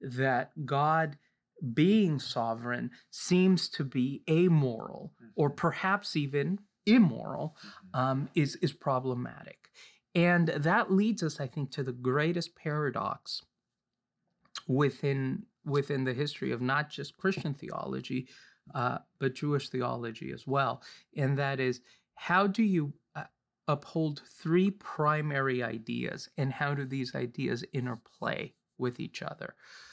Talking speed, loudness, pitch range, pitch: 120 wpm, -31 LUFS, 135-170 Hz, 145 Hz